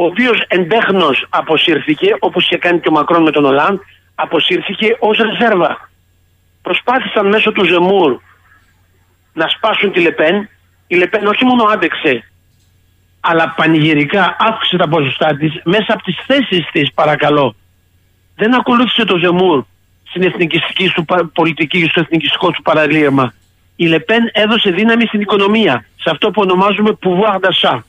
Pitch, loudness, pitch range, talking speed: 175 Hz, -12 LUFS, 145-210 Hz, 140 wpm